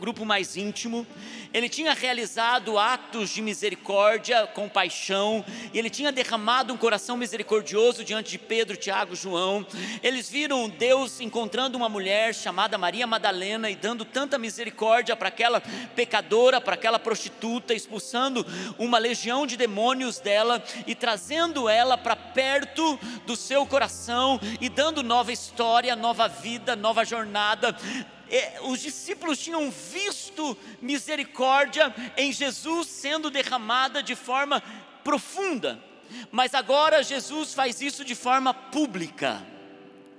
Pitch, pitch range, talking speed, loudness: 235 Hz, 220-265 Hz, 125 wpm, -25 LUFS